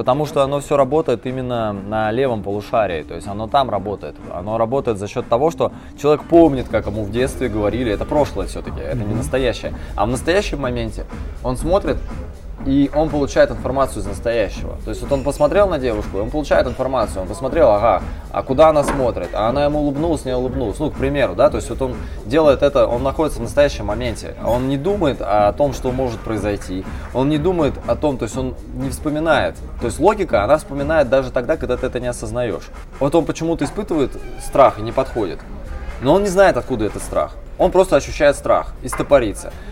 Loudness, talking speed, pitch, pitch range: -18 LUFS, 200 wpm, 130 Hz, 110-145 Hz